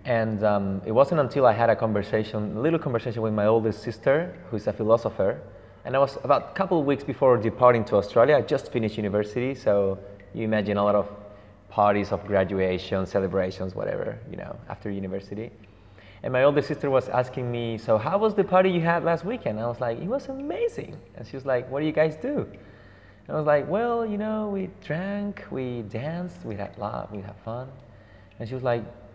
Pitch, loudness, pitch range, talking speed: 115 Hz, -25 LUFS, 100-145 Hz, 215 wpm